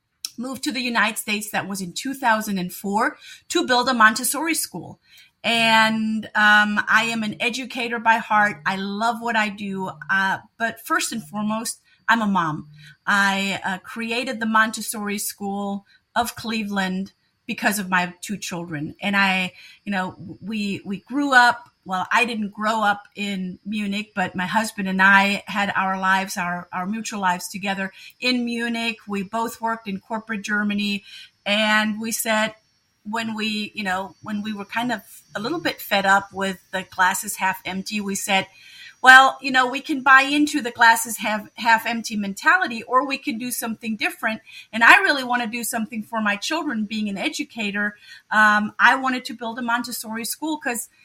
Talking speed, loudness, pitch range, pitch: 175 wpm, -21 LUFS, 195-235 Hz, 215 Hz